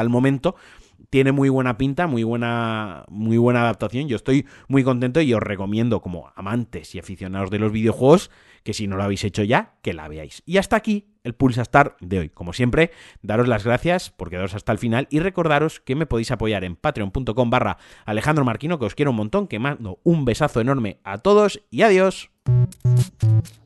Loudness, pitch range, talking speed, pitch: -21 LUFS, 105-140 Hz, 200 wpm, 120 Hz